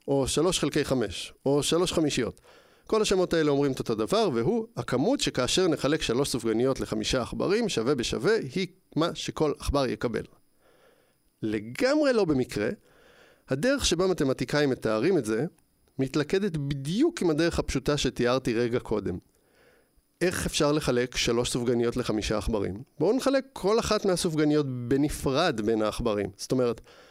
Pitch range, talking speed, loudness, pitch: 120-170 Hz, 140 wpm, -27 LUFS, 140 Hz